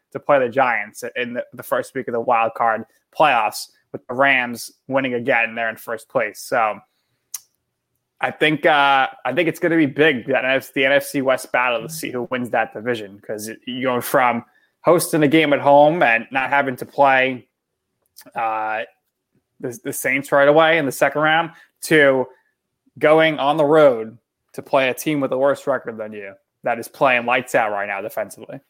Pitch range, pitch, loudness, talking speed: 125-150 Hz, 135 Hz, -18 LUFS, 190 wpm